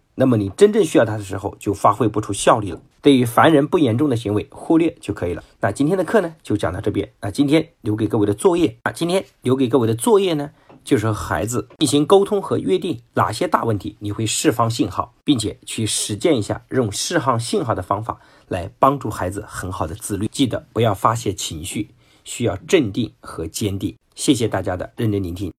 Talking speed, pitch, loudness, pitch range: 330 characters per minute, 115 Hz, -19 LUFS, 105-145 Hz